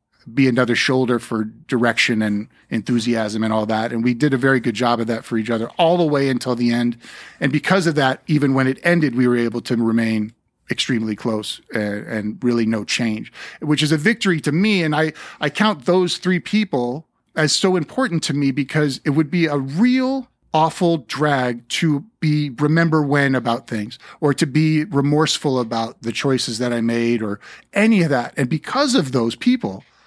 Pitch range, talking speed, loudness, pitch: 120-160 Hz, 200 wpm, -19 LUFS, 135 Hz